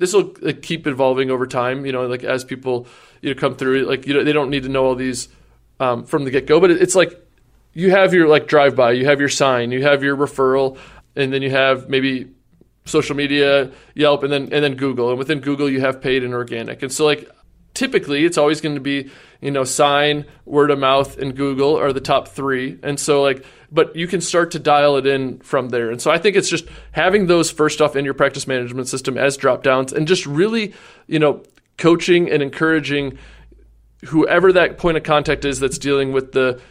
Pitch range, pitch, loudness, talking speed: 135-155 Hz, 140 Hz, -17 LUFS, 225 wpm